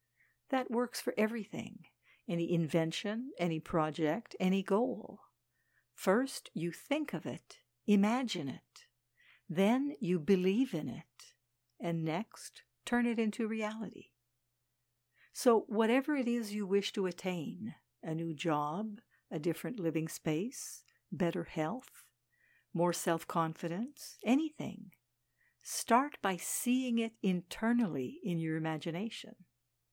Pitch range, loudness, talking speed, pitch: 165-230 Hz, -35 LUFS, 115 wpm, 195 Hz